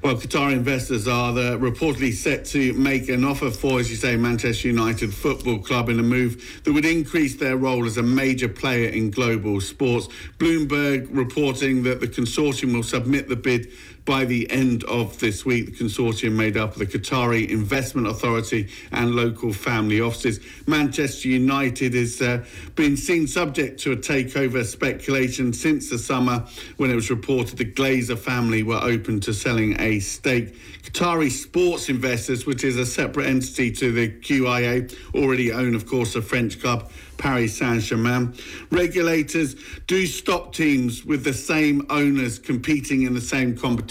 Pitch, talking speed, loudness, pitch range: 125 Hz, 165 wpm, -22 LUFS, 120-135 Hz